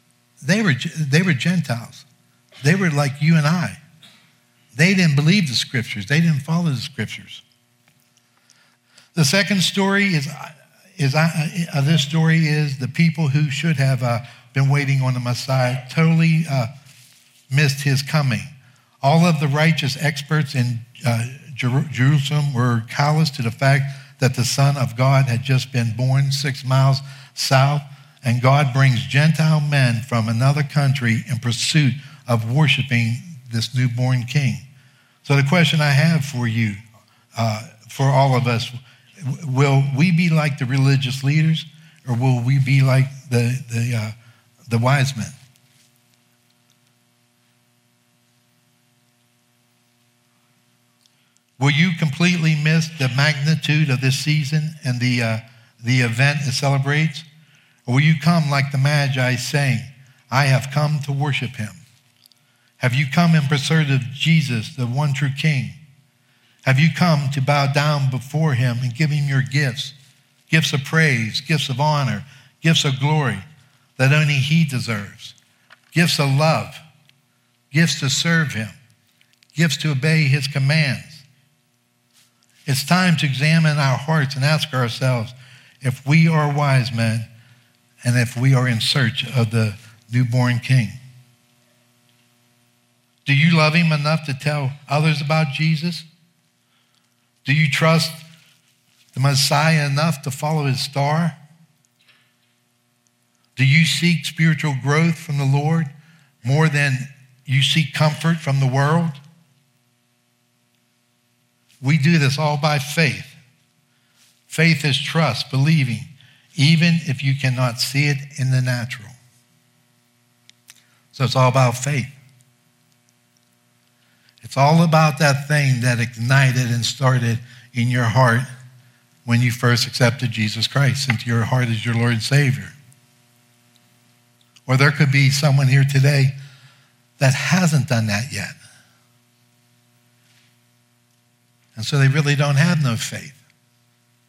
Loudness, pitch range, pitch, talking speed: -18 LUFS, 120-150 Hz, 135 Hz, 135 wpm